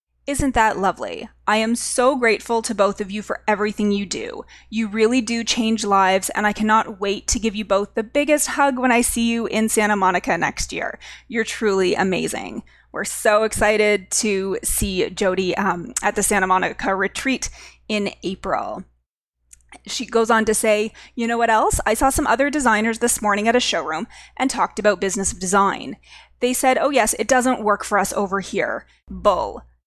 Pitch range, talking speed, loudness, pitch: 200-235 Hz, 185 wpm, -20 LUFS, 215 Hz